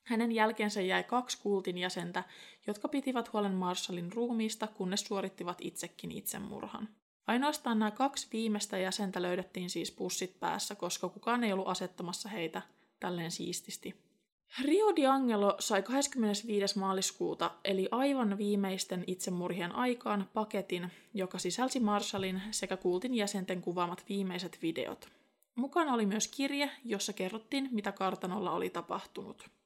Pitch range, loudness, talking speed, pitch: 185-230 Hz, -35 LUFS, 125 wpm, 205 Hz